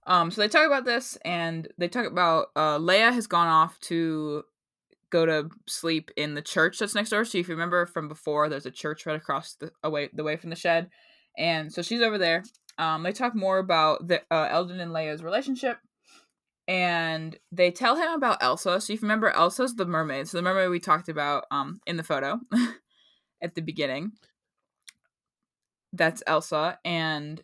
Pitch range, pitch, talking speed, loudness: 160-205 Hz, 170 Hz, 190 wpm, -26 LUFS